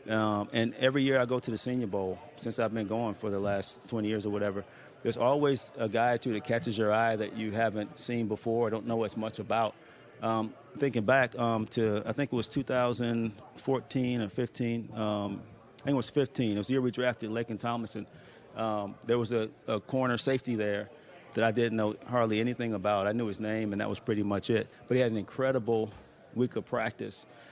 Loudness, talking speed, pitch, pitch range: -31 LUFS, 220 wpm, 115 Hz, 110-125 Hz